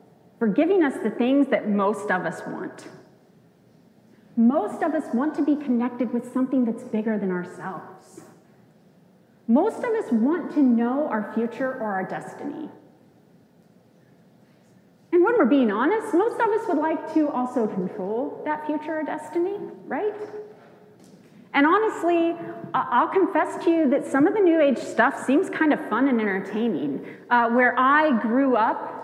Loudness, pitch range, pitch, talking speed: -23 LUFS, 225-320 Hz, 270 Hz, 155 wpm